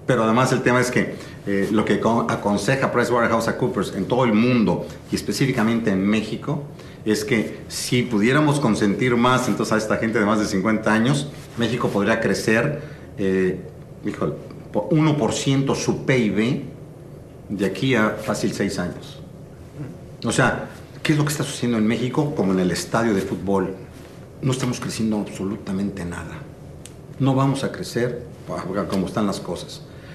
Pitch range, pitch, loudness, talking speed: 105-135 Hz, 115 Hz, -21 LUFS, 155 wpm